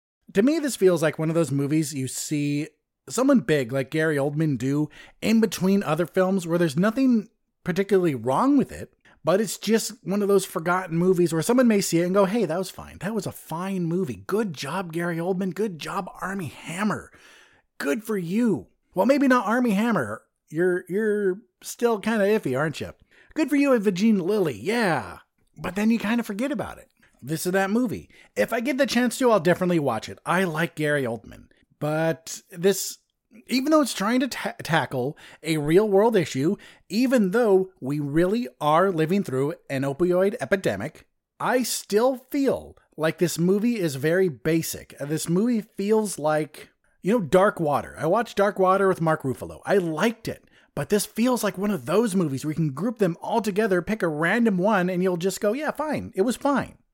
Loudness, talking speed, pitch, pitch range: -24 LUFS, 195 wpm, 190 Hz, 160-220 Hz